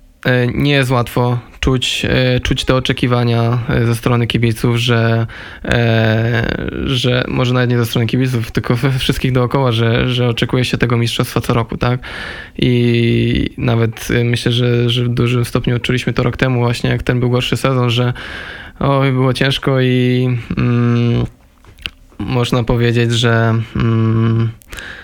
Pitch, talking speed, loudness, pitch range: 120 Hz, 140 wpm, -15 LUFS, 115-125 Hz